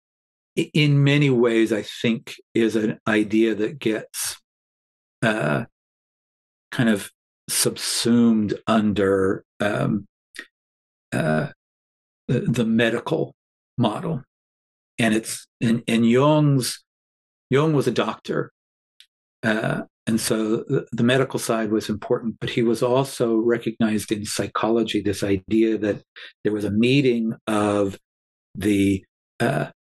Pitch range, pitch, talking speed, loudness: 100-120 Hz, 110 Hz, 110 wpm, -22 LUFS